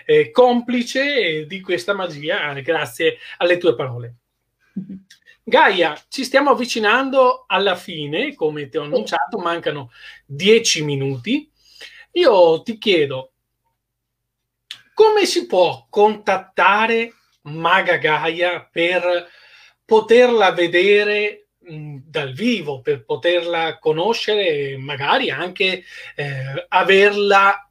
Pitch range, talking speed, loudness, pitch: 150-235 Hz, 95 wpm, -17 LUFS, 185 Hz